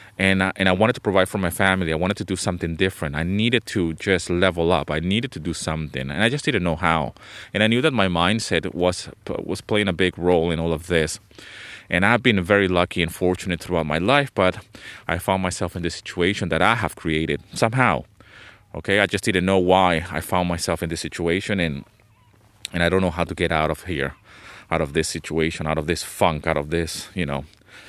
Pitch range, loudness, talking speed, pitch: 80-100 Hz, -22 LUFS, 230 wpm, 90 Hz